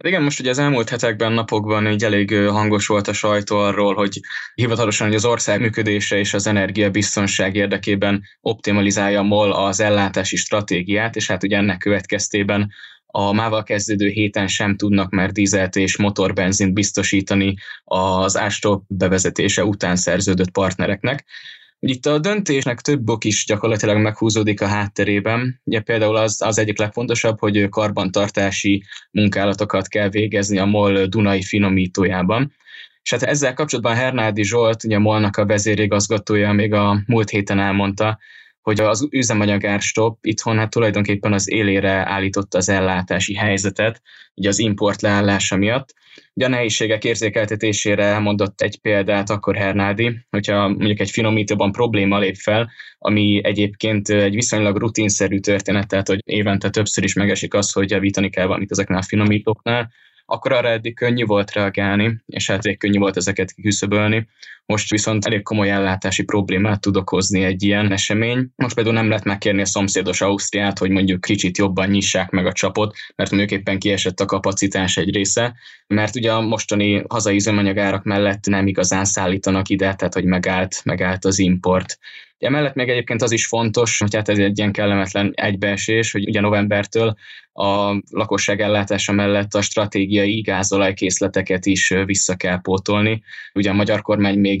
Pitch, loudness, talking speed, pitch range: 105 Hz, -18 LUFS, 155 wpm, 100-110 Hz